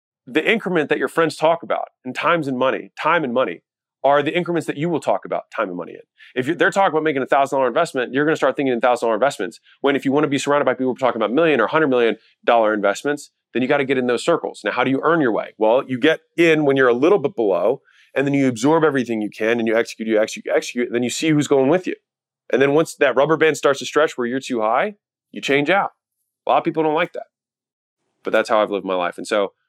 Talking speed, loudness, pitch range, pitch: 280 wpm, -19 LUFS, 125-155 Hz, 140 Hz